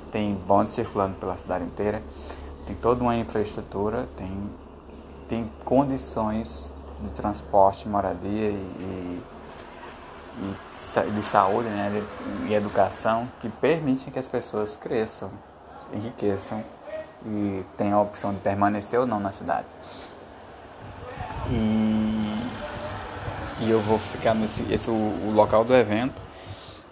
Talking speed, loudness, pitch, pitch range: 120 wpm, -26 LUFS, 105 Hz, 95-115 Hz